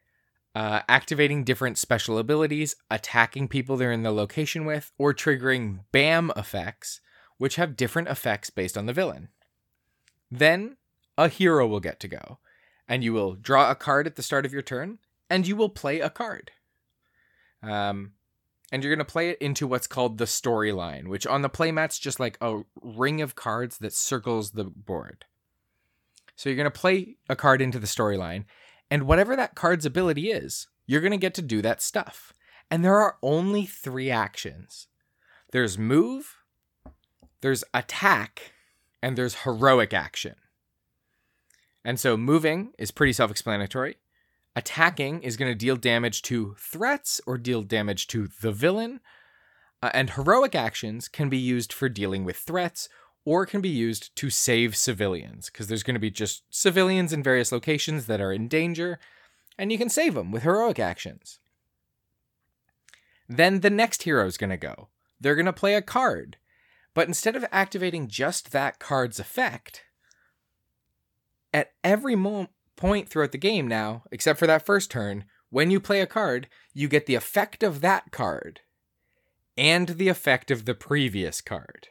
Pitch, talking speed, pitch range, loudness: 135 Hz, 165 wpm, 115-170 Hz, -25 LUFS